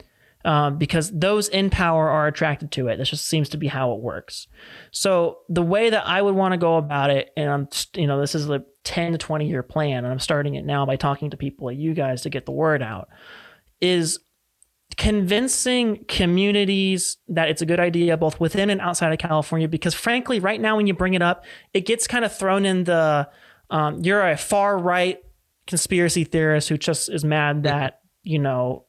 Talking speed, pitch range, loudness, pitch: 210 wpm, 145-190 Hz, -21 LUFS, 165 Hz